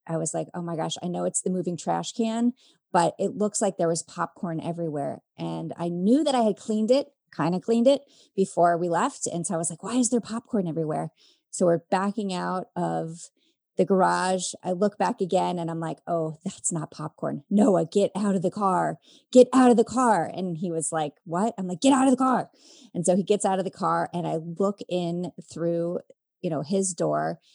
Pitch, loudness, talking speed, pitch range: 180 Hz, -25 LUFS, 225 wpm, 170-215 Hz